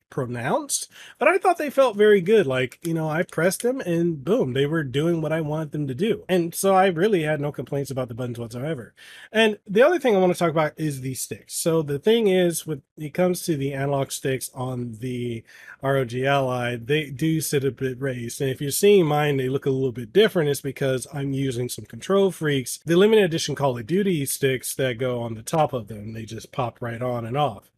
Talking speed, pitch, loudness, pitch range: 235 wpm, 145 Hz, -23 LUFS, 130-180 Hz